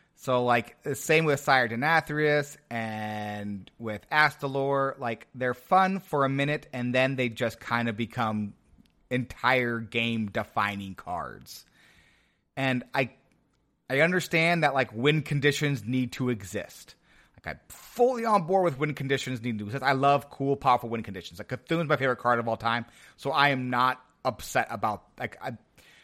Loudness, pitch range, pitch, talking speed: -27 LUFS, 115-145 Hz, 130 Hz, 165 wpm